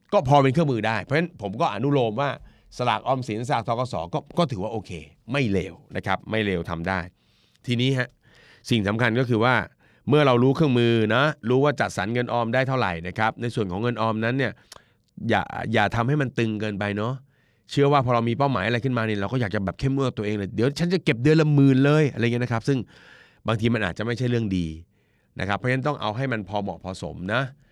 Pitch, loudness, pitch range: 120 Hz, -24 LUFS, 105-135 Hz